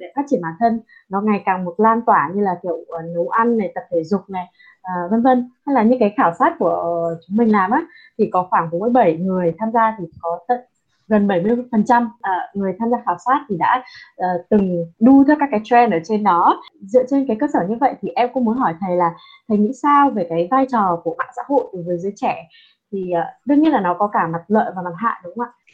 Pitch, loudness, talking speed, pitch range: 215 Hz, -18 LUFS, 255 wpm, 180-245 Hz